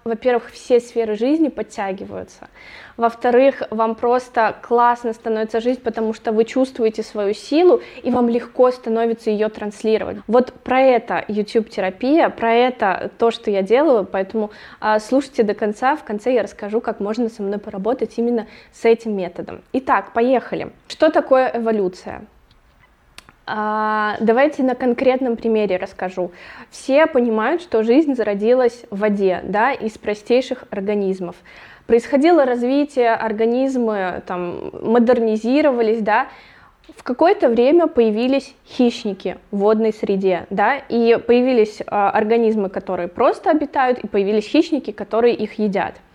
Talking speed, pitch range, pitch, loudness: 125 wpm, 210-250 Hz, 230 Hz, -18 LUFS